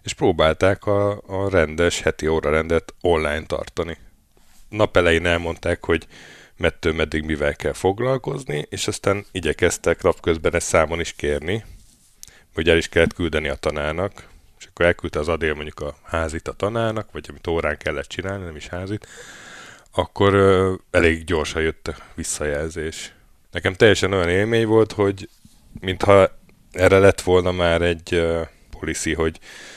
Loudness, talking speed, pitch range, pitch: -21 LUFS, 145 wpm, 80-100 Hz, 85 Hz